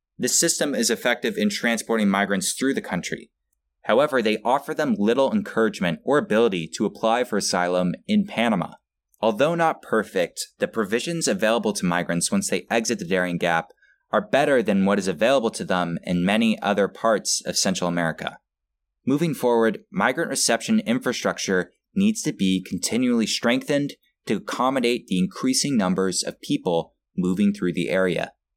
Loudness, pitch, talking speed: -23 LUFS, 110 Hz, 155 wpm